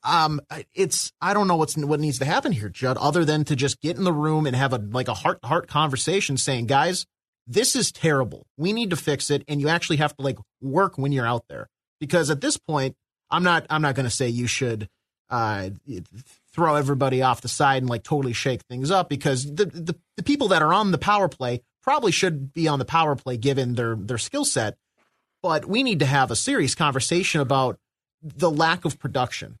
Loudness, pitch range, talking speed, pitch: -23 LUFS, 130-165 Hz, 225 wpm, 145 Hz